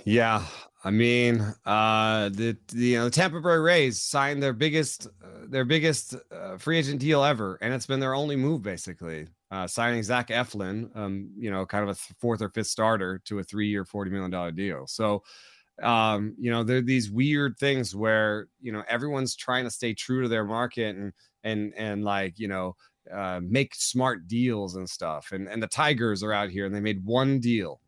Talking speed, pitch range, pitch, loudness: 205 wpm, 100-130 Hz, 110 Hz, -27 LUFS